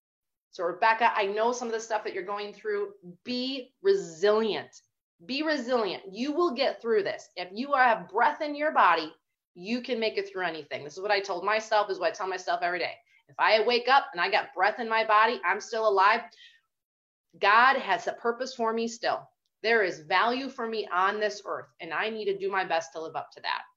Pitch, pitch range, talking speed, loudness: 220 Hz, 195-255 Hz, 220 wpm, -27 LUFS